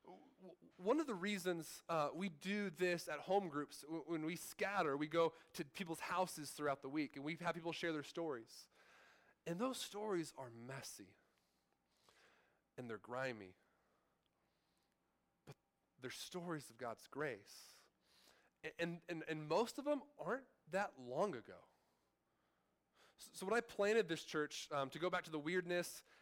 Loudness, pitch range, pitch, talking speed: -44 LUFS, 150-195 Hz, 170 Hz, 155 wpm